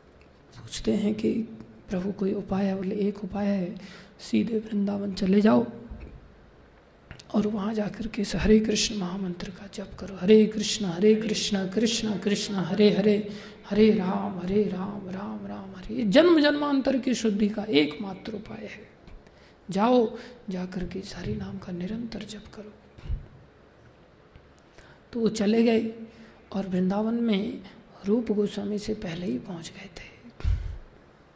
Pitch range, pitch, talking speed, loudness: 190-215 Hz, 205 Hz, 140 wpm, -26 LUFS